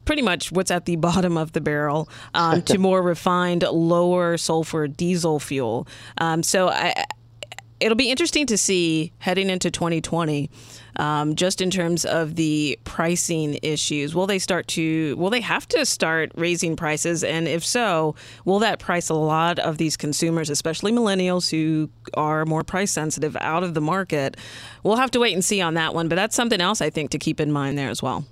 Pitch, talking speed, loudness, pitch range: 165 Hz, 195 wpm, -22 LUFS, 155-185 Hz